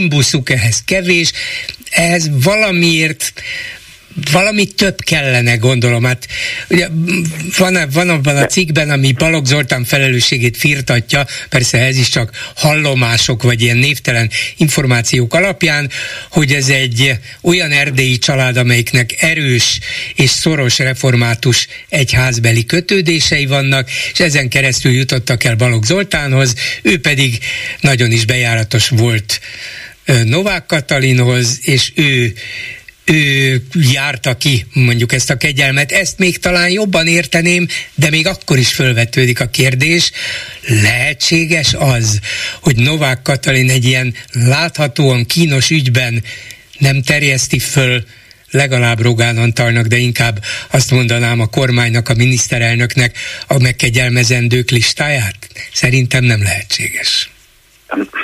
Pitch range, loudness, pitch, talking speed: 120-160 Hz, -12 LUFS, 135 Hz, 115 wpm